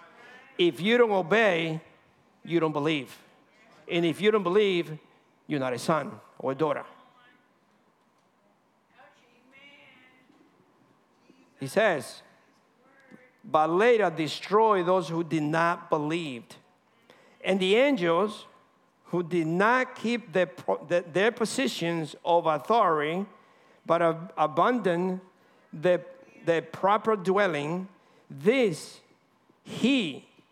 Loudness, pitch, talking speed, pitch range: -26 LUFS, 180 Hz, 100 wpm, 165-220 Hz